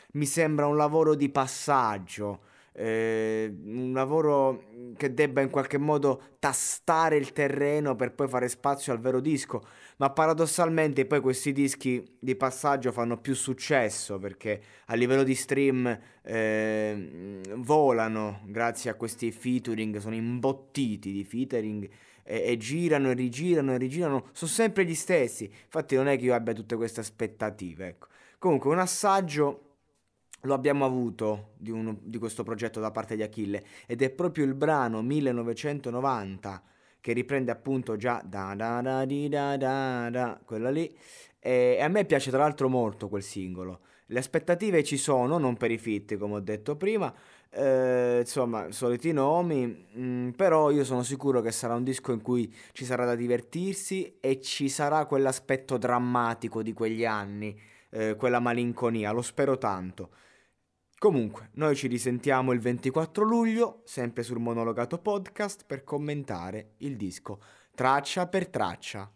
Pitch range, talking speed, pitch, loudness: 115-140 Hz, 155 wpm, 125 Hz, -28 LUFS